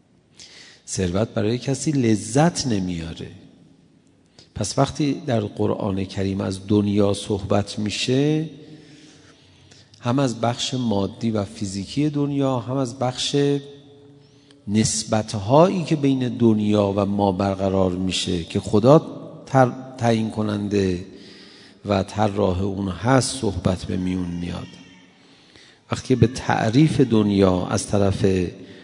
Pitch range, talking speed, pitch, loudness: 100-135 Hz, 105 wpm, 110 Hz, -21 LUFS